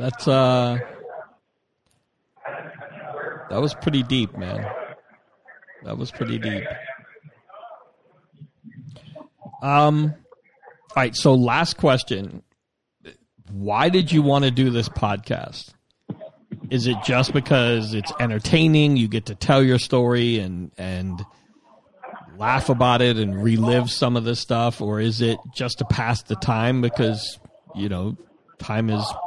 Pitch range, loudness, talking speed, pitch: 110-140 Hz, -21 LUFS, 125 wpm, 125 Hz